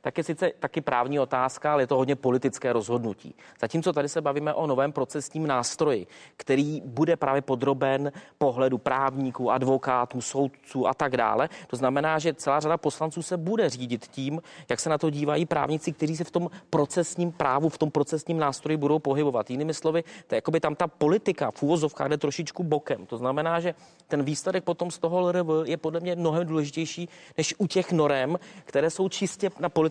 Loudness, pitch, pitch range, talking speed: -27 LUFS, 155 Hz, 135-170 Hz, 185 wpm